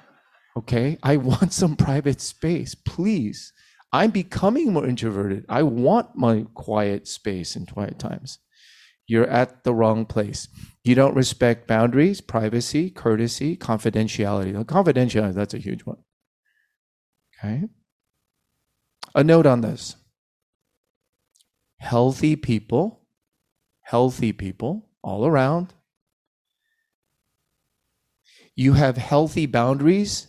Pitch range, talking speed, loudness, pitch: 115-155 Hz, 100 wpm, -22 LUFS, 125 Hz